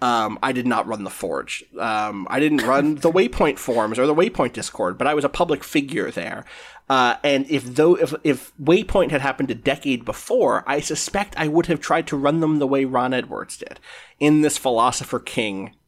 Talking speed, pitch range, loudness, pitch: 210 wpm, 125-160 Hz, -21 LUFS, 145 Hz